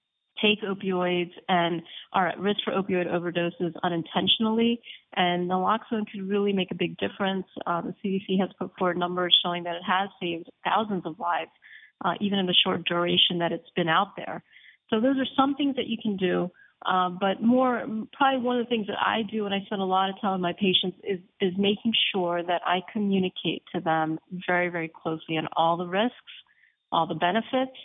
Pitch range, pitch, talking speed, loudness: 175-215 Hz, 190 Hz, 200 wpm, -26 LUFS